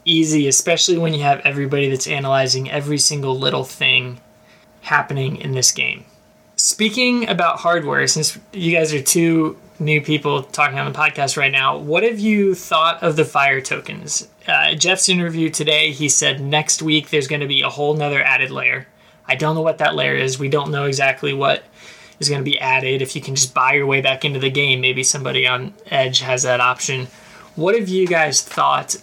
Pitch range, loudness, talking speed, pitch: 135-160 Hz, -17 LUFS, 200 wpm, 145 Hz